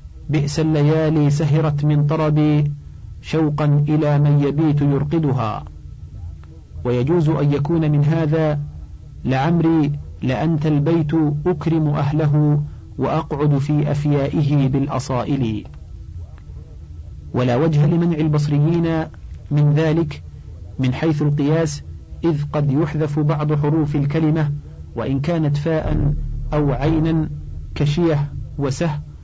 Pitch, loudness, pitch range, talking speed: 150 Hz, -19 LUFS, 130-155 Hz, 95 wpm